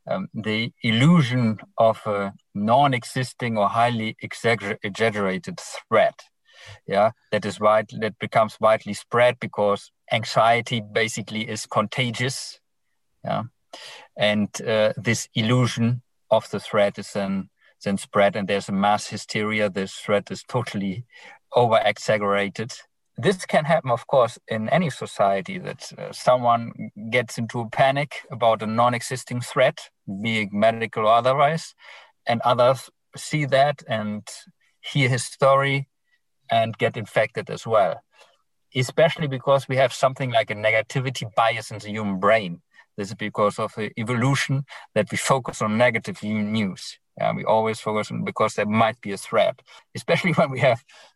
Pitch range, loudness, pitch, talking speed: 105-130 Hz, -22 LUFS, 115 Hz, 145 wpm